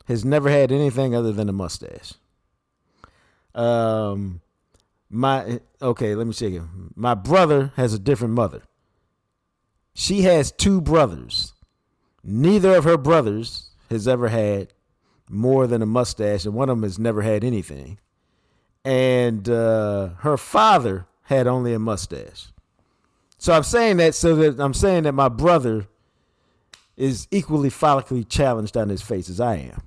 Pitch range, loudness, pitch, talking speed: 105-140 Hz, -20 LUFS, 120 Hz, 145 wpm